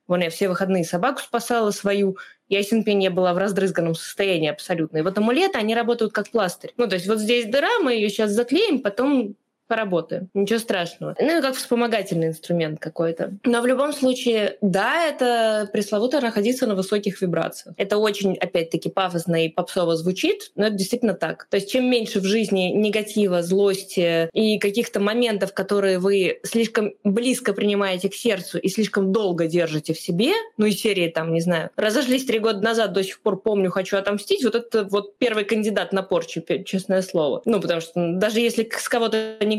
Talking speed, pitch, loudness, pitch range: 185 wpm, 205 Hz, -22 LUFS, 185-225 Hz